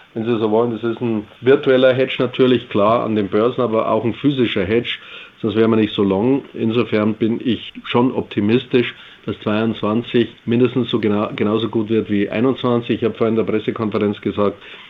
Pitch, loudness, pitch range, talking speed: 115 Hz, -18 LUFS, 110-120 Hz, 190 wpm